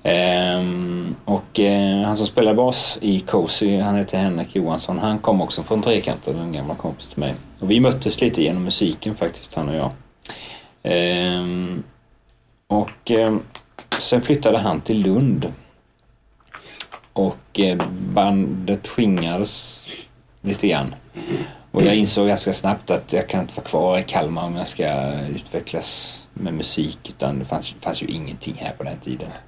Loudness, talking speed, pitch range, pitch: -21 LUFS, 155 wpm, 90-105 Hz, 100 Hz